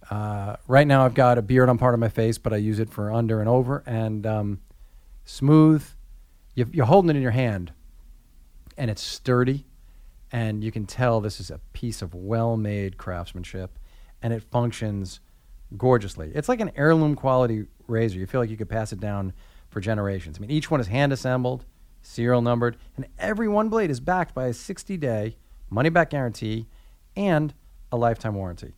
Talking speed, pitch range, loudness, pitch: 190 wpm, 100-130 Hz, -24 LUFS, 115 Hz